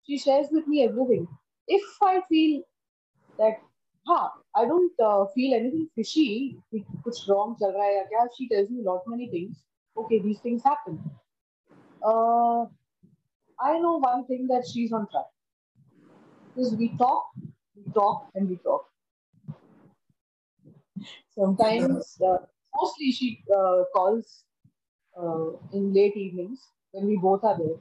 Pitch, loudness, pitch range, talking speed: 220 Hz, -26 LUFS, 195-255 Hz, 135 wpm